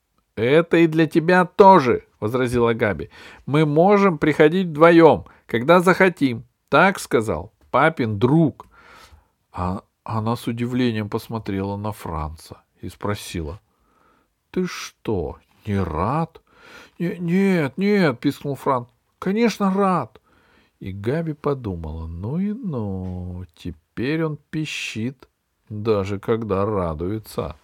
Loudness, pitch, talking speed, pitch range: -20 LUFS, 125 Hz, 105 wpm, 100-165 Hz